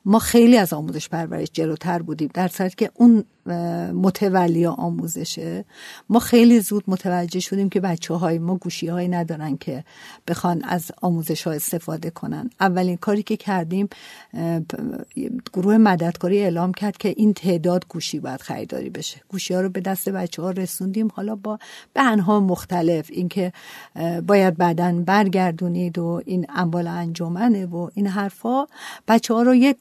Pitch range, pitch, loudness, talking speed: 170-205 Hz, 185 Hz, -21 LUFS, 150 wpm